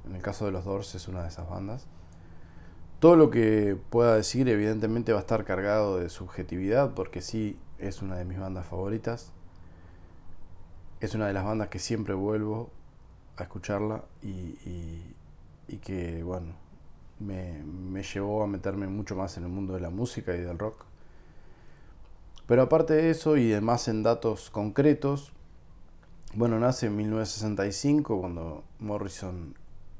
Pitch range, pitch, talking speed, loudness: 85-110 Hz, 95 Hz, 155 wpm, -28 LUFS